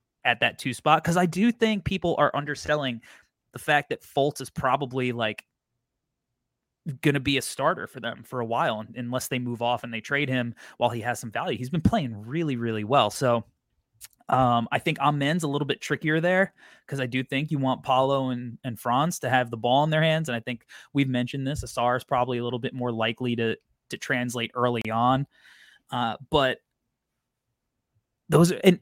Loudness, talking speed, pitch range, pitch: -26 LUFS, 200 wpm, 120-145 Hz, 130 Hz